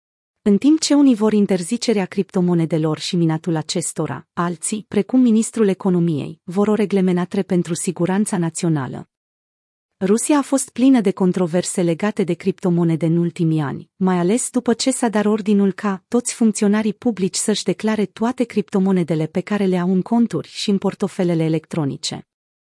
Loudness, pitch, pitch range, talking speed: -19 LUFS, 195 Hz, 175-215 Hz, 150 wpm